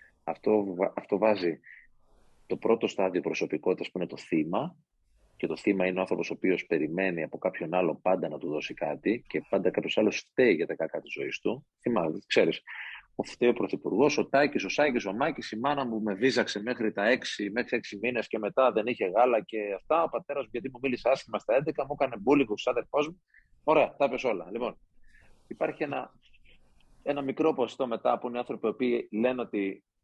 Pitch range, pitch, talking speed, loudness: 105-135 Hz, 120 Hz, 200 wpm, -29 LUFS